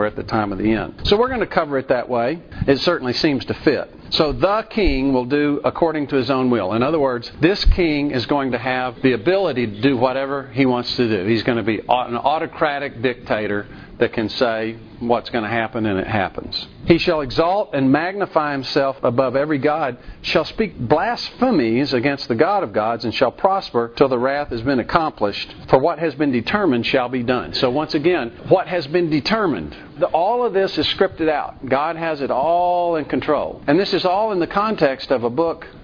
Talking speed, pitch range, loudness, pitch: 215 wpm, 120-165 Hz, -19 LUFS, 135 Hz